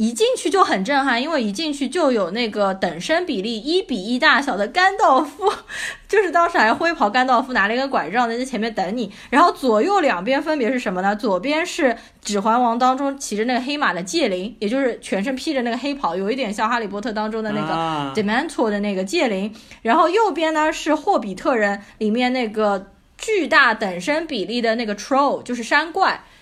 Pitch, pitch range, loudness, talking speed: 245 Hz, 215-300 Hz, -19 LUFS, 340 characters per minute